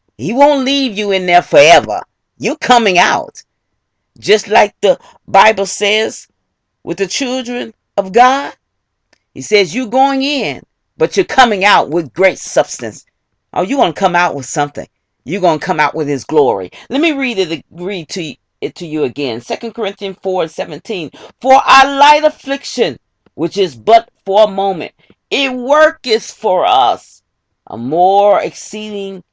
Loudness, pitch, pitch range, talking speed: -12 LUFS, 205 Hz, 175-255 Hz, 160 wpm